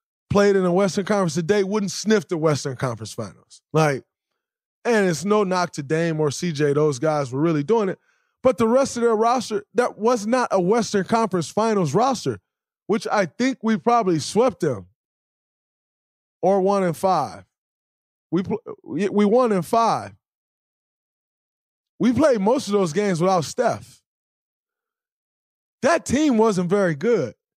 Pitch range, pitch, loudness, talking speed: 175-240 Hz, 205 Hz, -21 LUFS, 150 wpm